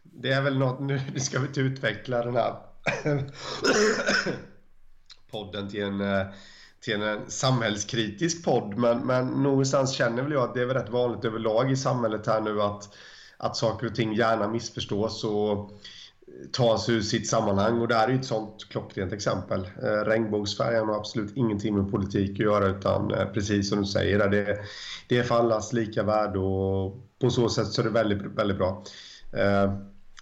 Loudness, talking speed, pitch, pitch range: -26 LUFS, 175 wpm, 110 Hz, 100-120 Hz